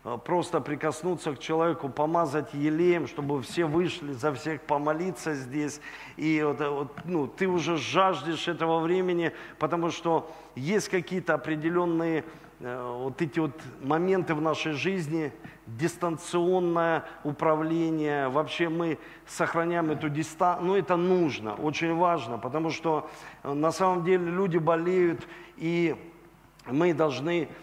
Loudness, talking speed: -28 LUFS, 120 wpm